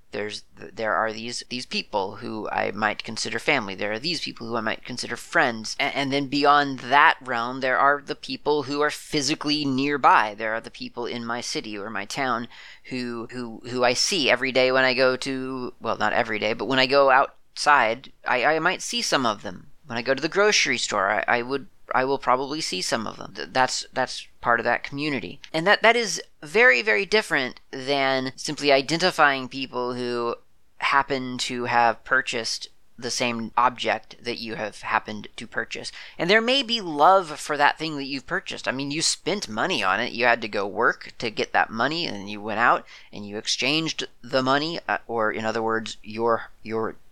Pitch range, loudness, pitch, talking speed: 115-145 Hz, -23 LUFS, 130 Hz, 205 wpm